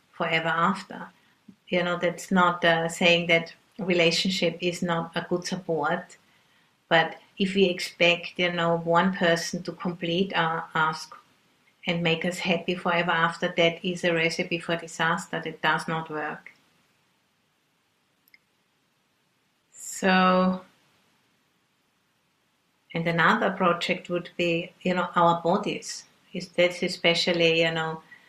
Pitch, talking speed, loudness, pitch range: 175 Hz, 120 wpm, -25 LUFS, 165-180 Hz